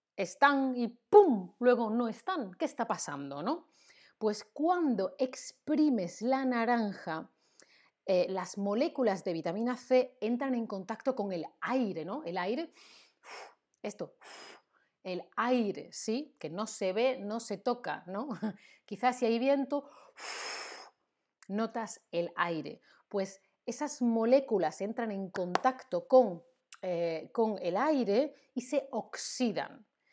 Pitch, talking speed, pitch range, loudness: 230 Hz, 125 wpm, 200-260 Hz, -32 LUFS